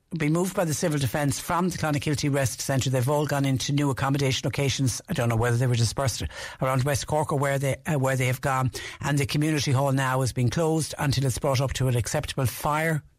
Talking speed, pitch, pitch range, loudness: 235 wpm, 140 Hz, 130-150 Hz, -25 LUFS